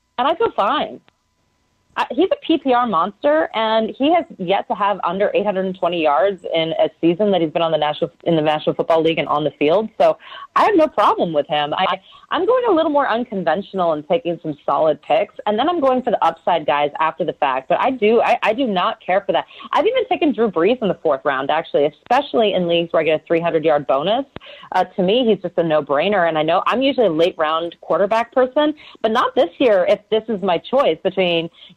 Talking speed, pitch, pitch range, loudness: 235 wpm, 195 Hz, 165-255 Hz, -18 LUFS